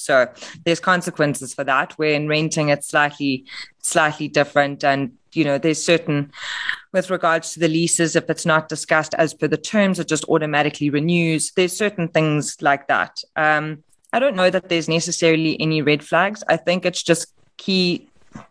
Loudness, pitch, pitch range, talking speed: -19 LUFS, 160 Hz, 150-170 Hz, 200 wpm